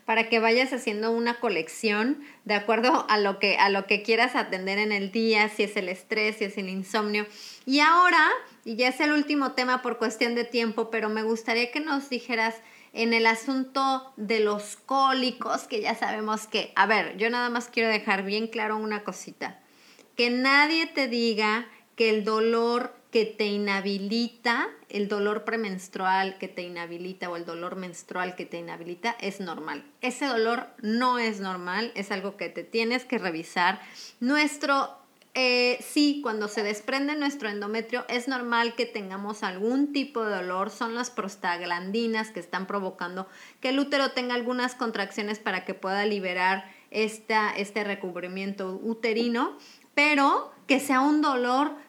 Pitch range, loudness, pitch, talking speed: 200-245 Hz, -26 LUFS, 225 Hz, 165 wpm